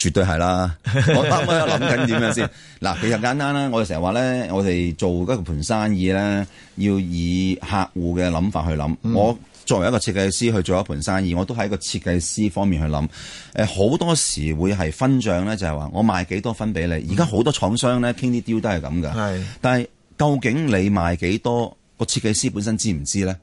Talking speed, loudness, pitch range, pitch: 315 characters per minute, -21 LUFS, 90-115 Hz, 100 Hz